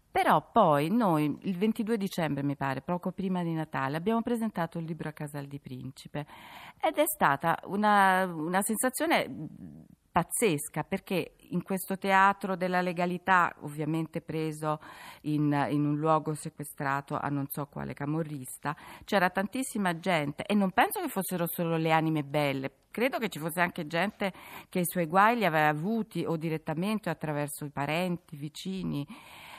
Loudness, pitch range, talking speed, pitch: -29 LUFS, 150-190 Hz, 160 wpm, 170 Hz